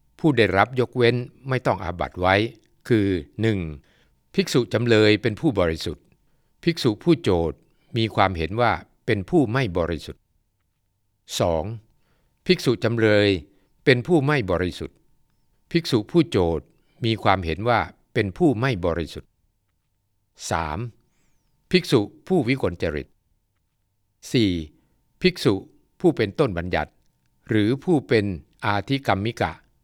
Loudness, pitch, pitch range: -22 LUFS, 110 Hz, 90-130 Hz